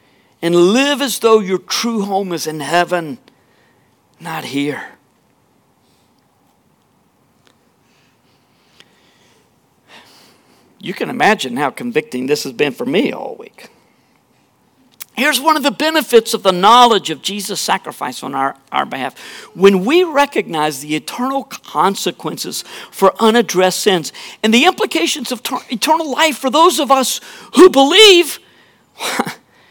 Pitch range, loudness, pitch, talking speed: 170-285 Hz, -14 LUFS, 225 Hz, 125 wpm